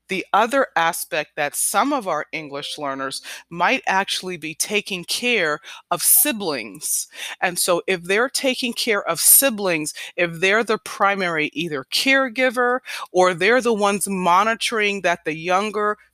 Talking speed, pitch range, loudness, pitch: 140 wpm, 165-225 Hz, -19 LUFS, 190 Hz